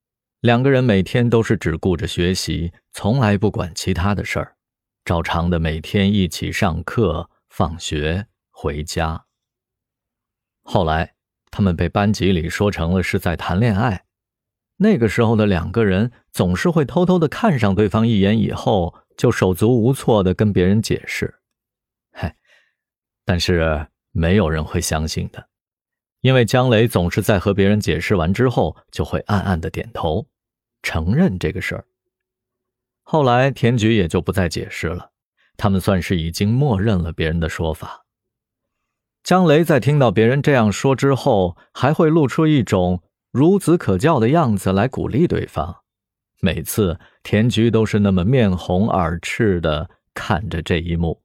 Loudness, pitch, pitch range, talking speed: -18 LUFS, 105 Hz, 90-120 Hz, 225 characters per minute